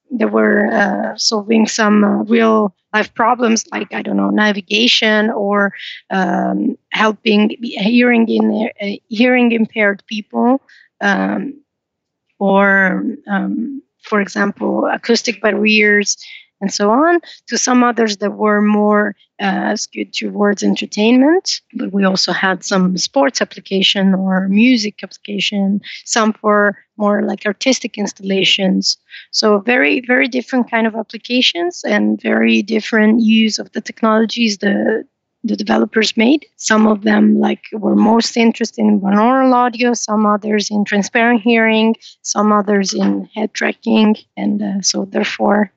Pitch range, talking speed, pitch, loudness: 200-230 Hz, 125 wpm, 215 Hz, -14 LUFS